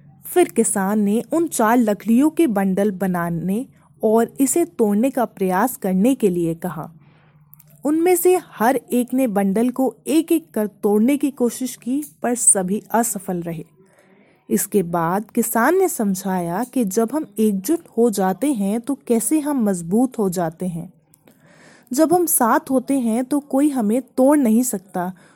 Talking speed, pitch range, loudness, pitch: 160 wpm, 195-265 Hz, -19 LUFS, 225 Hz